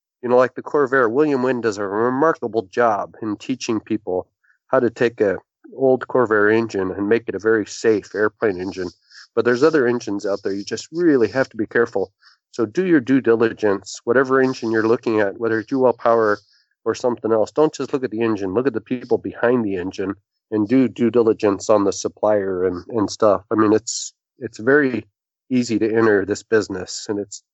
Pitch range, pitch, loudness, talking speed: 105-125 Hz, 115 Hz, -19 LUFS, 205 wpm